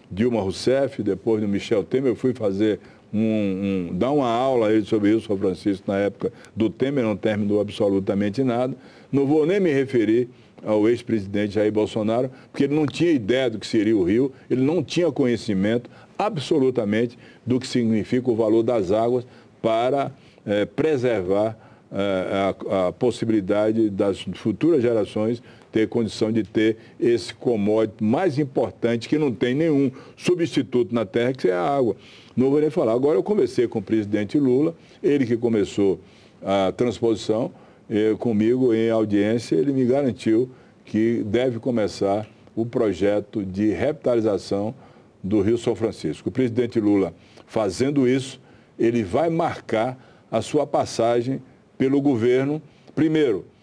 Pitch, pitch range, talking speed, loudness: 115 Hz, 105-130 Hz, 150 wpm, -22 LUFS